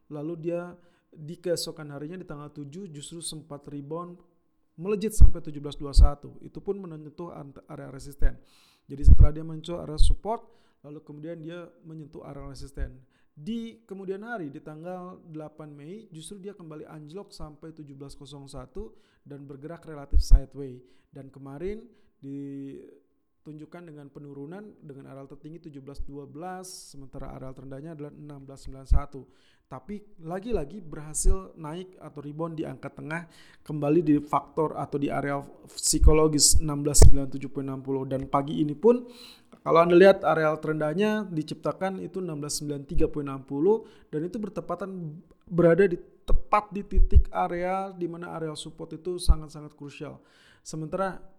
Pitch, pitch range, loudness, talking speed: 155 Hz, 145-175 Hz, -27 LUFS, 125 wpm